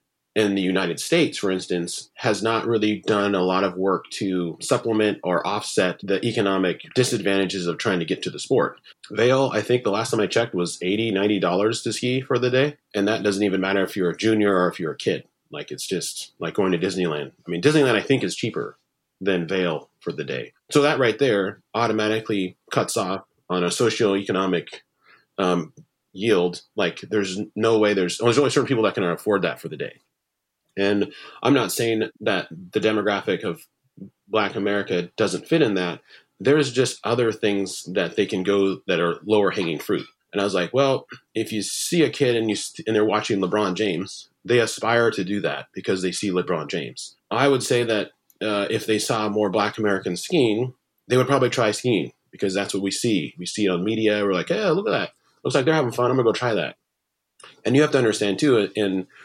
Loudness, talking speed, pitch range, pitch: -22 LUFS, 215 wpm, 95-115 Hz, 105 Hz